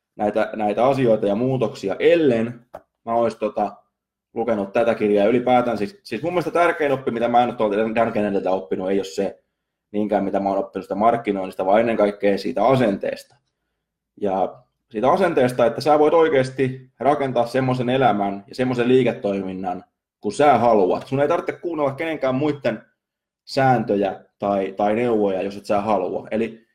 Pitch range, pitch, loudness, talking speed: 100-130 Hz, 115 Hz, -20 LUFS, 160 wpm